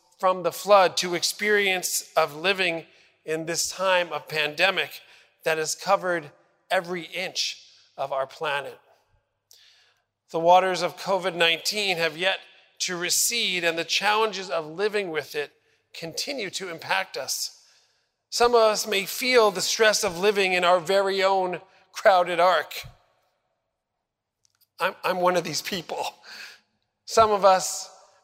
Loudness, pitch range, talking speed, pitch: -23 LUFS, 175-205 Hz, 135 wpm, 185 Hz